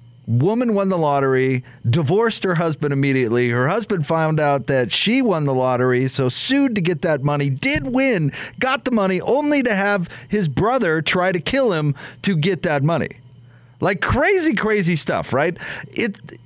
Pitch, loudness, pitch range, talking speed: 160 Hz, -18 LUFS, 135-200 Hz, 170 wpm